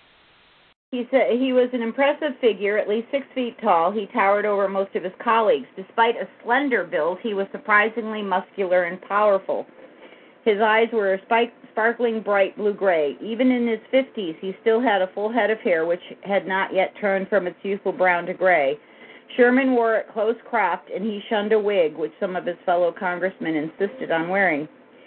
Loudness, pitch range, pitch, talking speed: -22 LUFS, 190-230 Hz, 205 Hz, 180 wpm